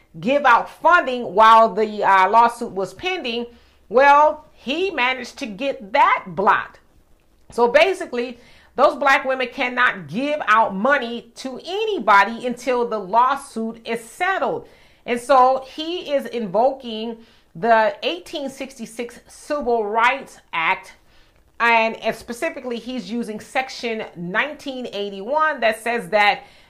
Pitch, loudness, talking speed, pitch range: 240 Hz, -19 LUFS, 115 wpm, 225-275 Hz